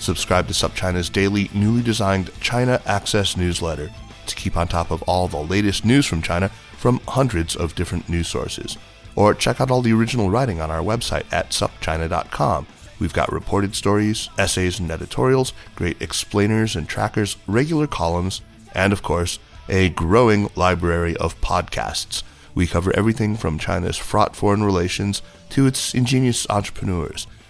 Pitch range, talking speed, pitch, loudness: 85-110 Hz, 155 wpm, 100 Hz, -20 LUFS